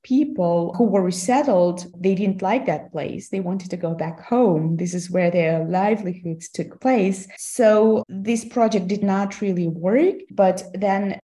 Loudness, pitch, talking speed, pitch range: -21 LUFS, 195 Hz, 165 wpm, 180-215 Hz